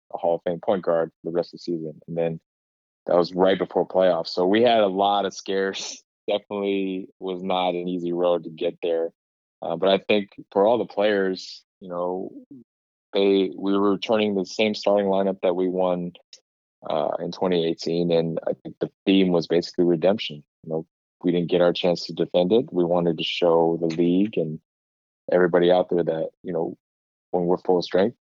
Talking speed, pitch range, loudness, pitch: 200 wpm, 85-95 Hz, -23 LUFS, 90 Hz